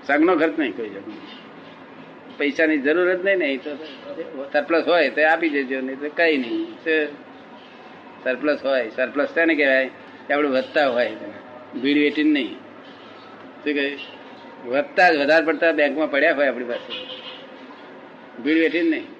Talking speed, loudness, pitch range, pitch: 115 wpm, -20 LUFS, 140-165 Hz, 150 Hz